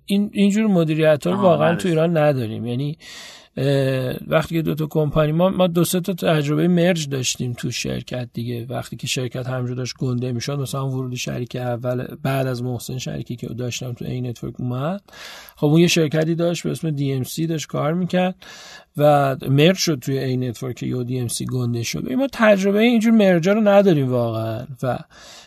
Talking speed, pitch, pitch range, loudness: 180 wpm, 145 Hz, 125-175 Hz, -20 LUFS